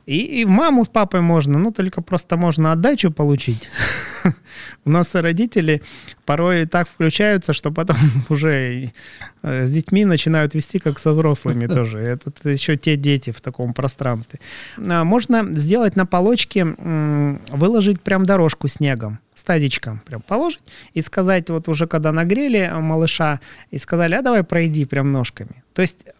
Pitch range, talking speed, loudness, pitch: 140-185 Hz, 145 wpm, -18 LUFS, 160 Hz